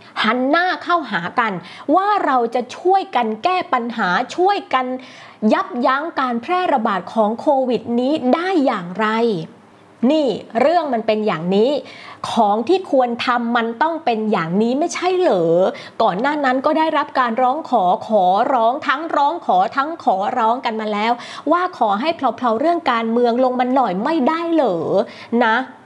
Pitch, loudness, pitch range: 255 Hz, -18 LUFS, 230-320 Hz